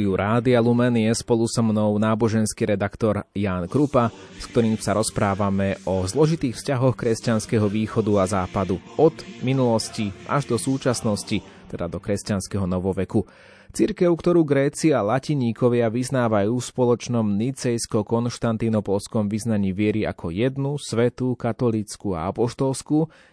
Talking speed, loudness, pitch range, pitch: 120 wpm, -22 LUFS, 100-125 Hz, 115 Hz